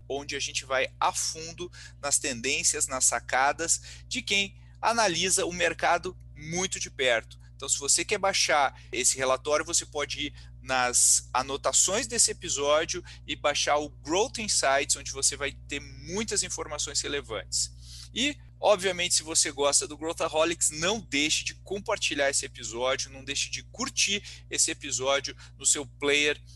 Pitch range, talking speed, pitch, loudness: 125-160 Hz, 150 wpm, 140 Hz, -26 LUFS